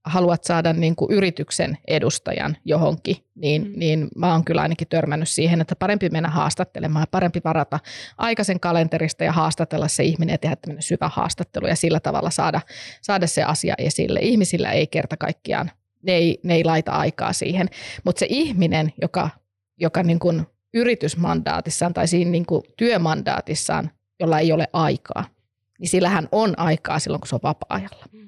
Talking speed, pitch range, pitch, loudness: 160 wpm, 155-180 Hz, 165 Hz, -21 LUFS